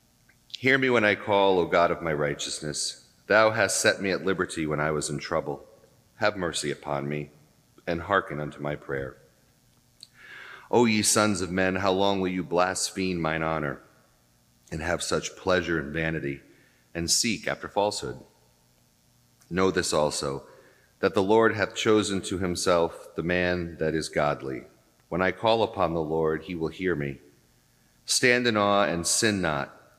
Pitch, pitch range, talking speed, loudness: 85 Hz, 70-95 Hz, 165 wpm, -26 LUFS